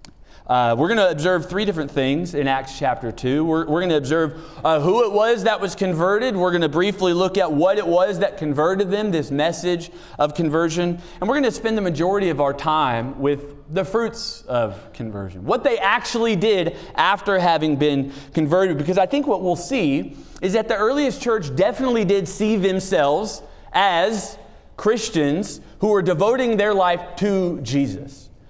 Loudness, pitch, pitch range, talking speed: -20 LUFS, 175 Hz, 150-205 Hz, 185 wpm